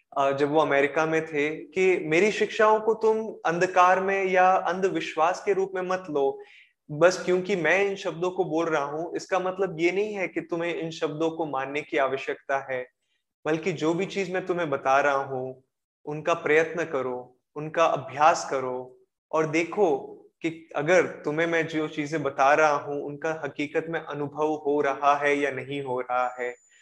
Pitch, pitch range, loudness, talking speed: 160 Hz, 140-185 Hz, -25 LUFS, 180 wpm